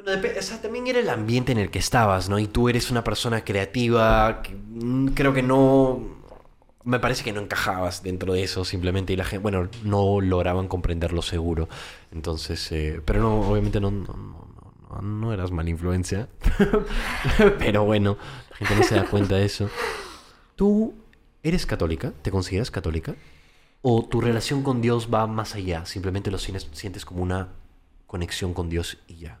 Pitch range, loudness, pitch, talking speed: 90-120 Hz, -24 LUFS, 100 Hz, 175 wpm